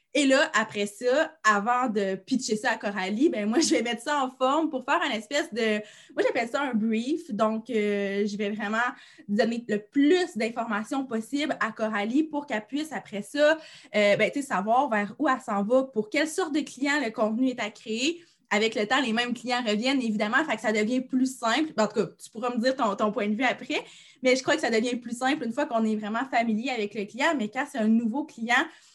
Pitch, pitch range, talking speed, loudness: 240 Hz, 215-280 Hz, 235 wpm, -26 LUFS